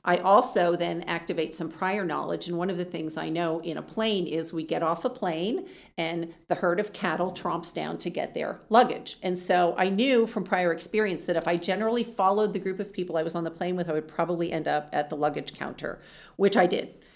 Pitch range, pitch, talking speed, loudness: 165-195 Hz, 175 Hz, 240 wpm, -27 LUFS